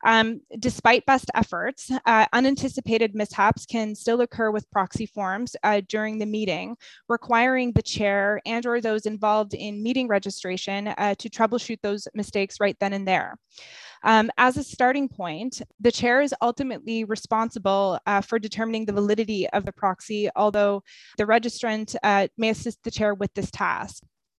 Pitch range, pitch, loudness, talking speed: 205-235 Hz, 220 Hz, -24 LUFS, 160 wpm